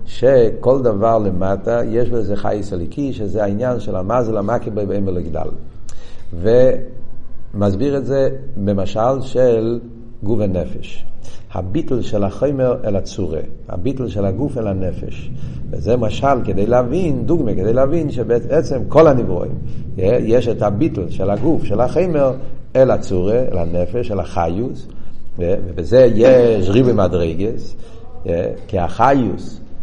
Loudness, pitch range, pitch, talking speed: -17 LUFS, 100-125 Hz, 115 Hz, 125 wpm